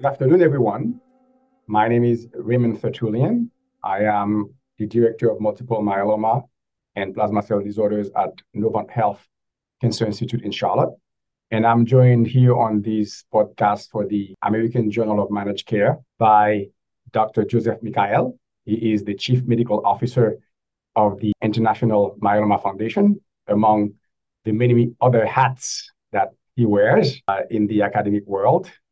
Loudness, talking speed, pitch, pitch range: -20 LUFS, 140 wpm, 110 Hz, 105-120 Hz